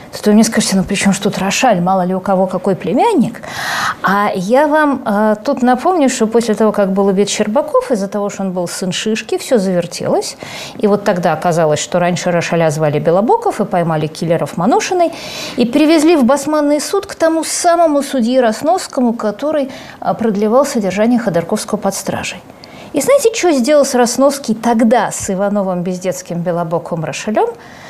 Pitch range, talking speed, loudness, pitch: 185-275 Hz, 165 wpm, -14 LUFS, 215 Hz